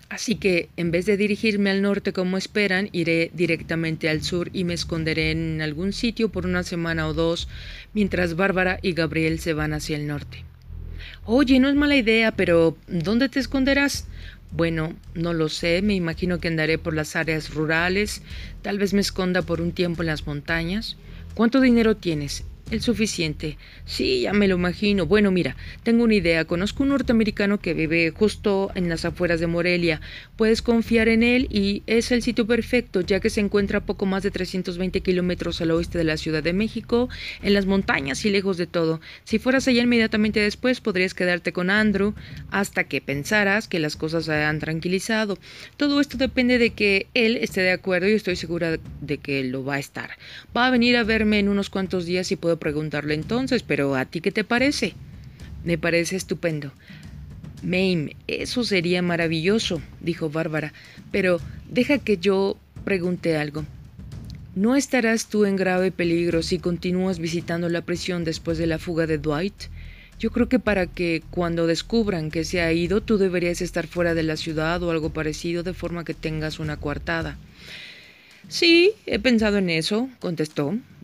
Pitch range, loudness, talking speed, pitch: 165-210 Hz, -23 LUFS, 180 wpm, 180 Hz